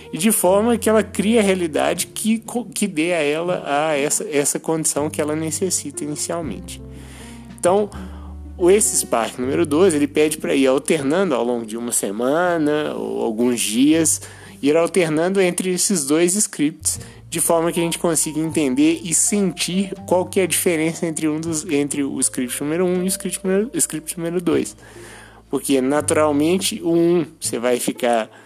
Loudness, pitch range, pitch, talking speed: -19 LUFS, 135-180 Hz, 160 Hz, 175 wpm